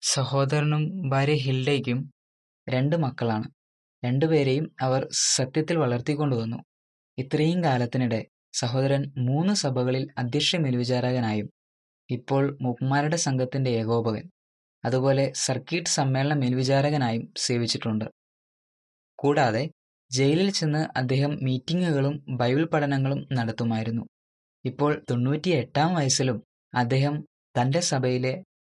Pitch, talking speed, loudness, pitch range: 130 Hz, 85 wpm, -25 LUFS, 120-145 Hz